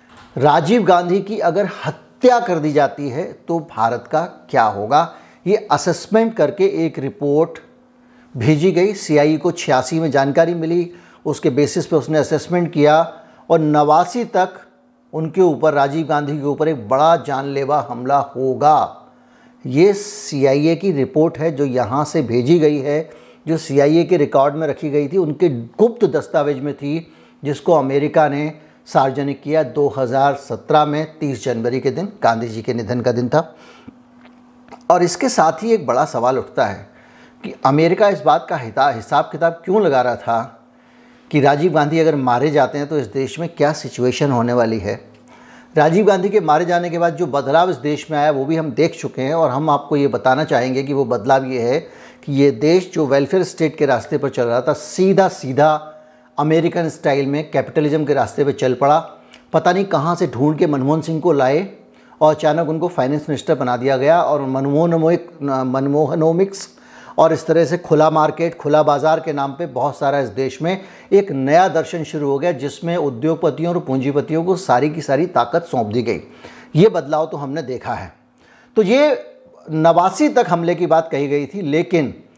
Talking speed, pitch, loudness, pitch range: 185 wpm, 155 Hz, -17 LUFS, 140-170 Hz